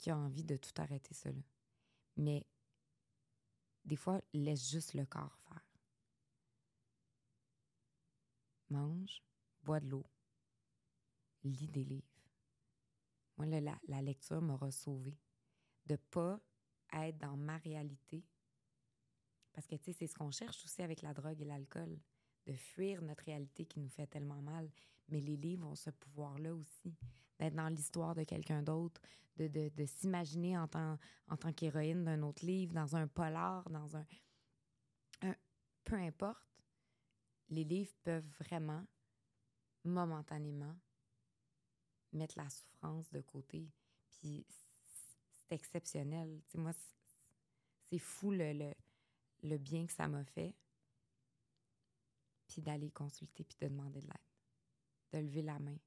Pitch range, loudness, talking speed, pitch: 135-160 Hz, -45 LUFS, 140 wpm, 150 Hz